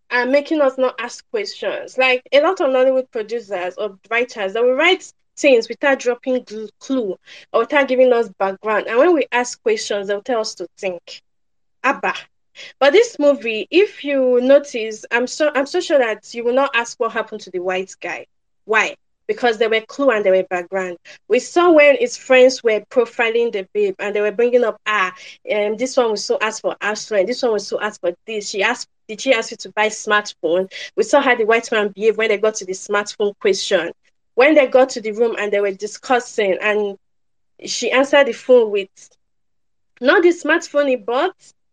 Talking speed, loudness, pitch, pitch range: 210 wpm, -17 LUFS, 235 Hz, 210-265 Hz